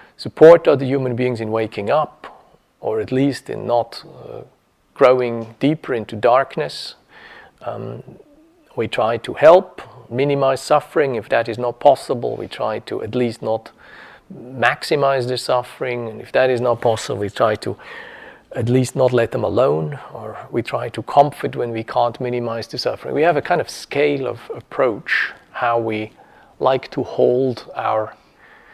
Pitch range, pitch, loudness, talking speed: 115-135 Hz, 125 Hz, -18 LUFS, 165 wpm